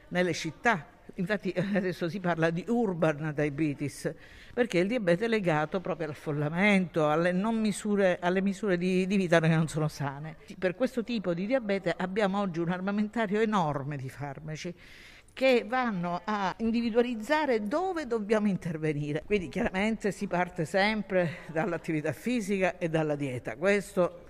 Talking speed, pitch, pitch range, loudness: 145 wpm, 185 Hz, 160-210 Hz, -29 LUFS